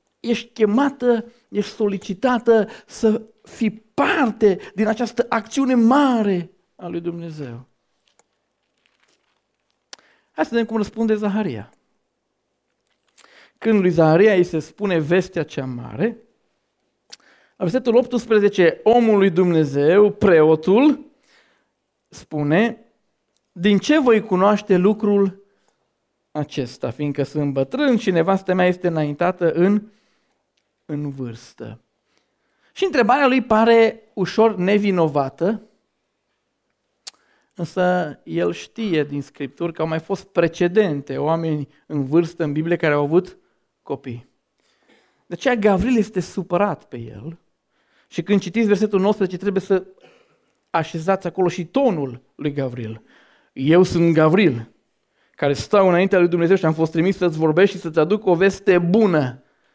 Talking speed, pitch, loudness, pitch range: 120 wpm, 185 Hz, -19 LUFS, 160-220 Hz